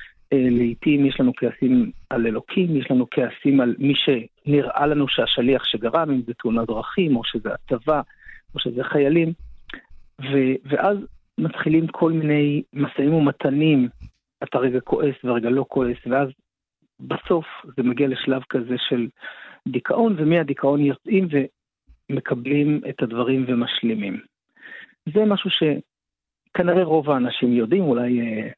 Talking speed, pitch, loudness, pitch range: 125 wpm, 135 Hz, -21 LUFS, 125-150 Hz